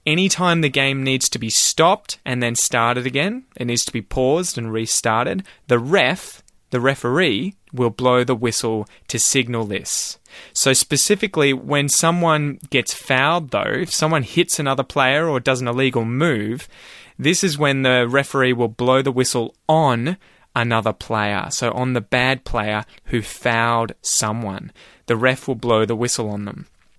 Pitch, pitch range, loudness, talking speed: 125 Hz, 115-145 Hz, -19 LUFS, 165 wpm